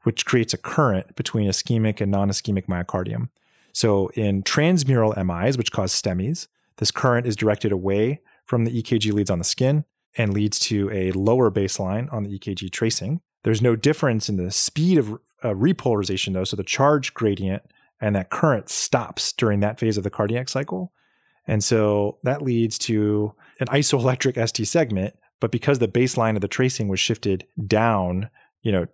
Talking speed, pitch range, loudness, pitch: 175 wpm, 100-125 Hz, -22 LUFS, 110 Hz